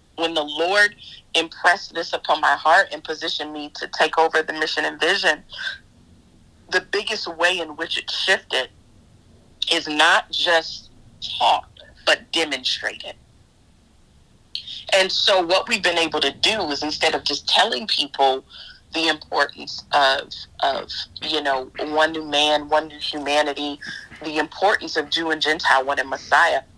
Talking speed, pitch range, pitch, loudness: 150 wpm, 140-165 Hz, 155 Hz, -20 LUFS